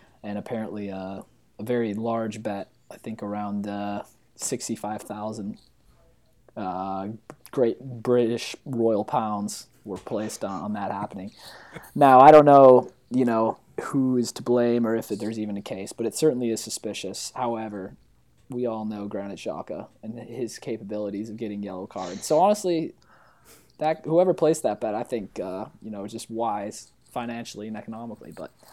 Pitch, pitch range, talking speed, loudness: 110 Hz, 105-120 Hz, 150 wpm, -24 LUFS